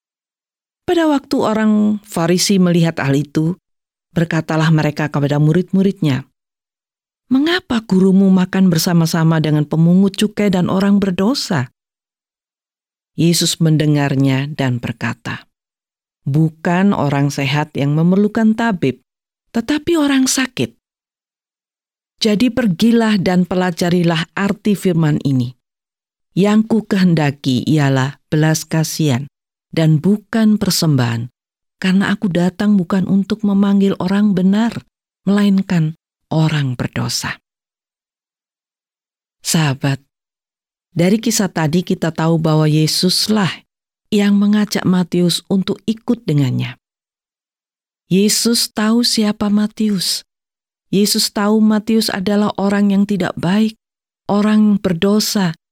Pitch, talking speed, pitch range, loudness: 185 Hz, 95 wpm, 155-210 Hz, -15 LUFS